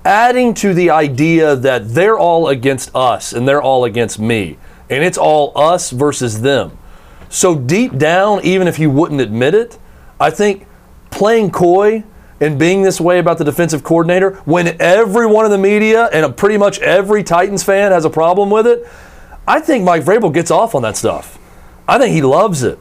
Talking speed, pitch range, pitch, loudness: 185 wpm, 145-200 Hz, 175 Hz, -12 LUFS